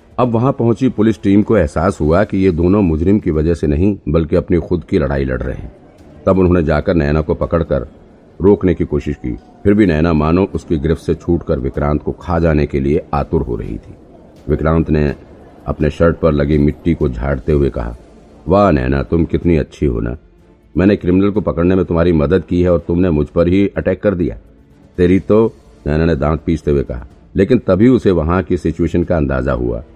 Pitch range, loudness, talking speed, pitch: 75-95 Hz, -15 LUFS, 210 wpm, 85 Hz